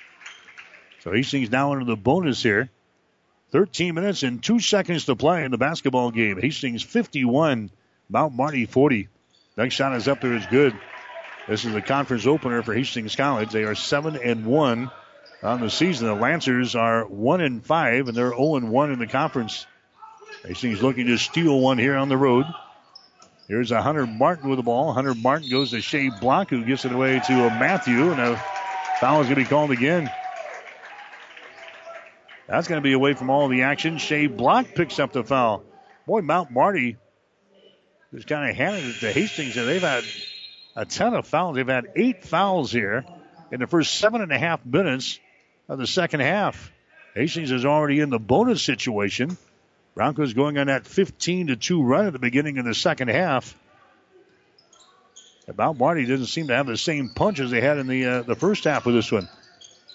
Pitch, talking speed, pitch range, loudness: 135 Hz, 190 wpm, 125-160 Hz, -22 LUFS